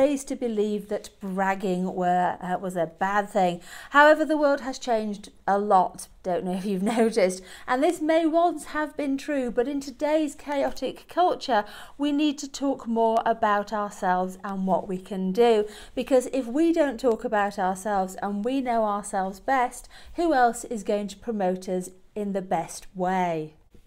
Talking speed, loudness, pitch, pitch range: 175 wpm, -25 LUFS, 215 Hz, 190-270 Hz